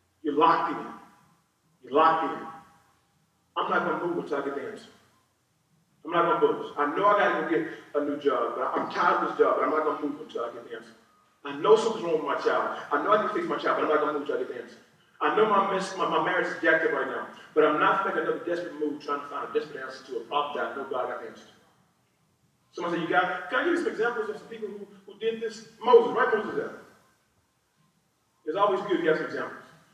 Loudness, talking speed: -26 LUFS, 275 wpm